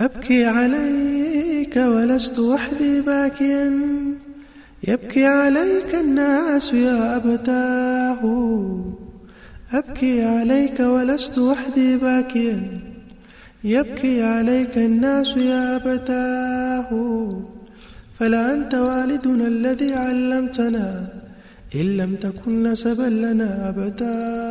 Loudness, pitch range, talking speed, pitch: -20 LUFS, 230-270 Hz, 75 wpm, 250 Hz